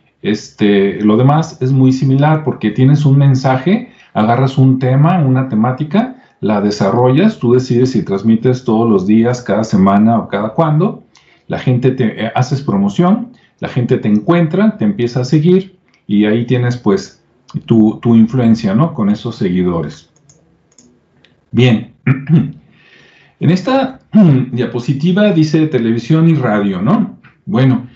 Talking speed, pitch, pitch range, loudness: 135 wpm, 130 Hz, 115-160 Hz, -12 LUFS